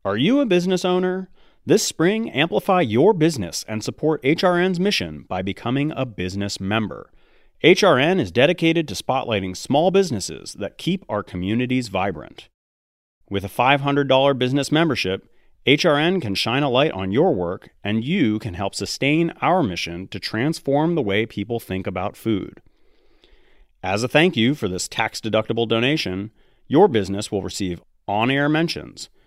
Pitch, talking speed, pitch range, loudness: 115 Hz, 155 wpm, 100-155 Hz, -20 LUFS